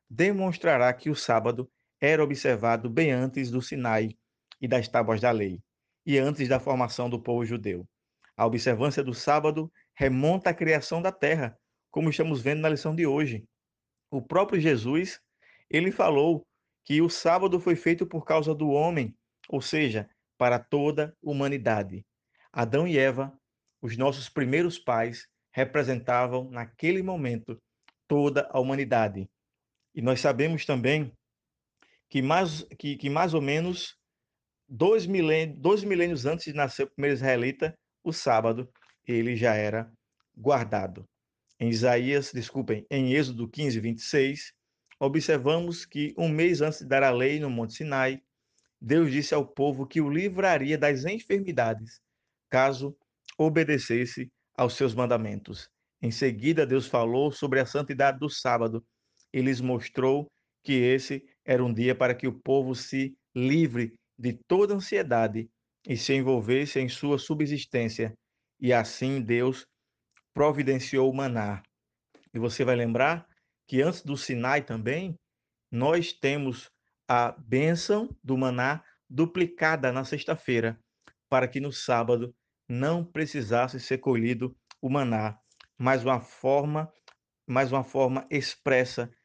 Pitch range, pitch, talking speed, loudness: 120-150 Hz, 135 Hz, 135 wpm, -27 LUFS